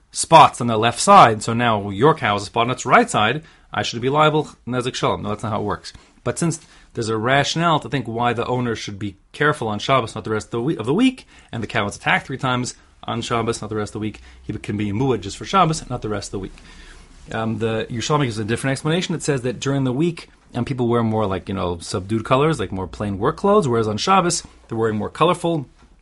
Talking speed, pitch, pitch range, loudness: 260 wpm, 115 Hz, 105-140 Hz, -20 LUFS